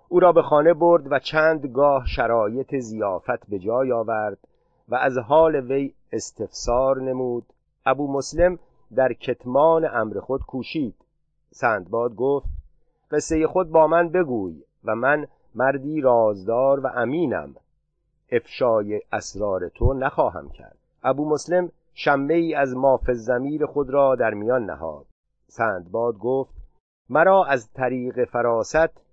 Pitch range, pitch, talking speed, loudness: 125-155 Hz, 135 Hz, 130 wpm, -22 LUFS